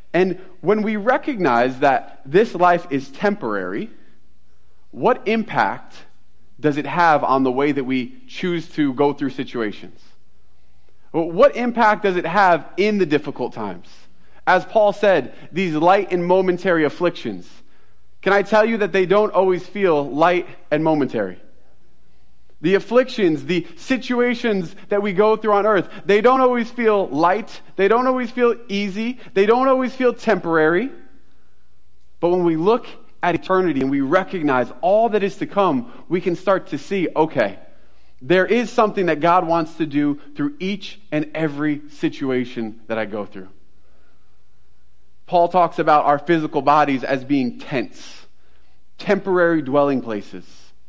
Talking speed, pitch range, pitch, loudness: 150 wpm, 130-200 Hz, 170 Hz, -19 LUFS